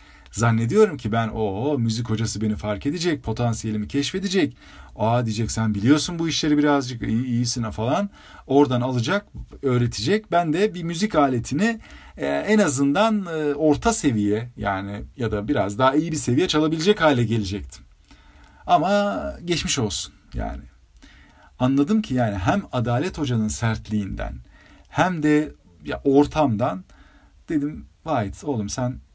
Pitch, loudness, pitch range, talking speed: 125 Hz, -22 LUFS, 105-150 Hz, 125 wpm